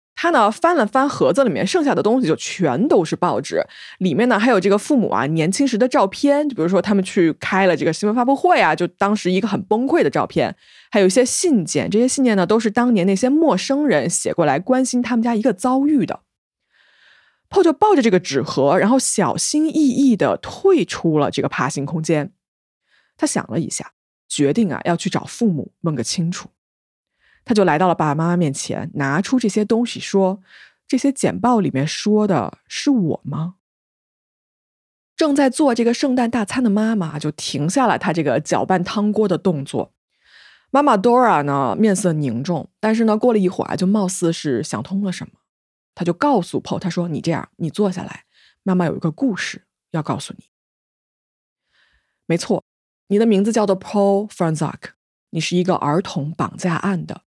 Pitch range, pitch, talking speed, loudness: 170-245 Hz, 200 Hz, 295 characters per minute, -18 LUFS